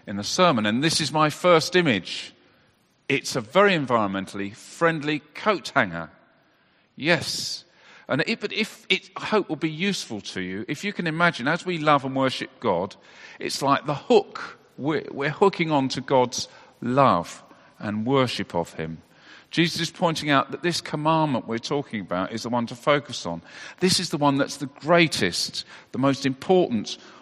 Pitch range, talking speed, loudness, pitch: 120-170 Hz, 175 wpm, -23 LUFS, 145 Hz